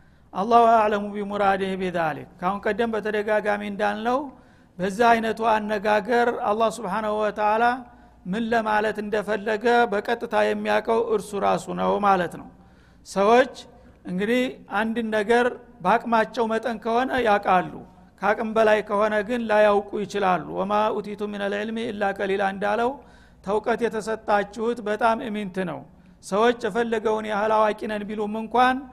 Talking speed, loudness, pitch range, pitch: 110 wpm, -23 LUFS, 205-230 Hz, 215 Hz